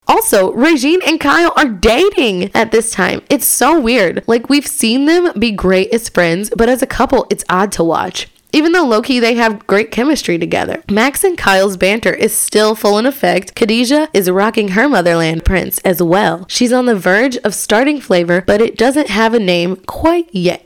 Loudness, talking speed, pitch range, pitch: -12 LUFS, 200 wpm, 190-270 Hz, 225 Hz